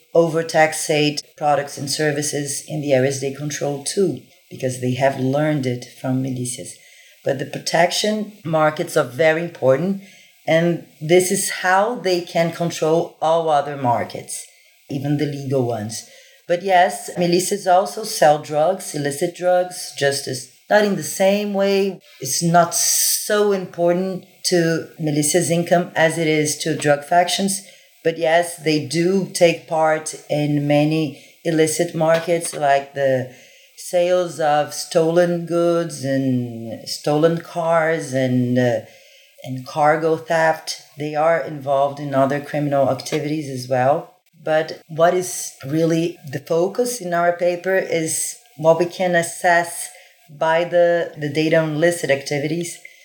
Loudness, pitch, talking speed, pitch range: -19 LUFS, 160 Hz, 135 wpm, 145-175 Hz